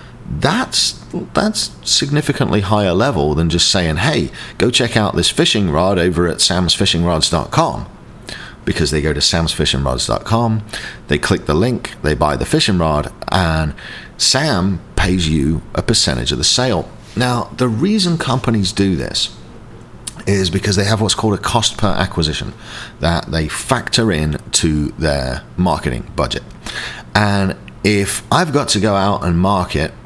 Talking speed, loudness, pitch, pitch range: 150 wpm, -16 LUFS, 95 Hz, 80-110 Hz